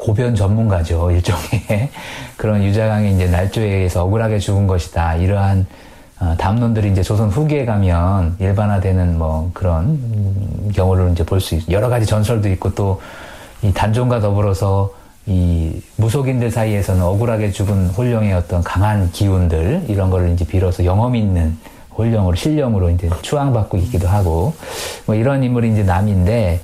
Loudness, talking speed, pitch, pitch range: -17 LUFS, 340 characters per minute, 100 Hz, 90-110 Hz